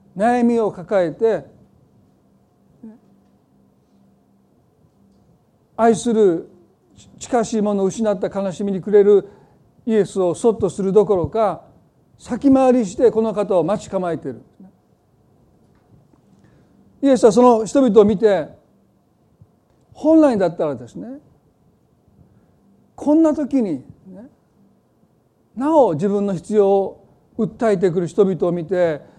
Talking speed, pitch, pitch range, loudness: 200 characters per minute, 205 Hz, 190-235 Hz, -17 LUFS